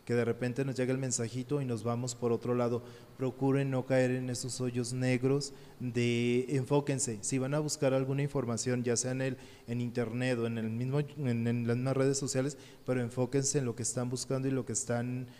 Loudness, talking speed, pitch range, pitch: -33 LUFS, 215 wpm, 120-135 Hz, 125 Hz